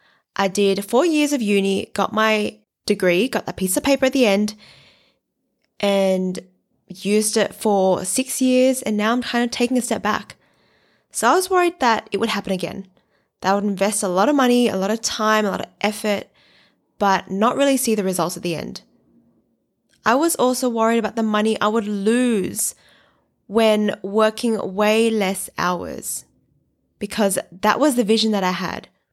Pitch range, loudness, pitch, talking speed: 195-235 Hz, -20 LUFS, 215 Hz, 185 wpm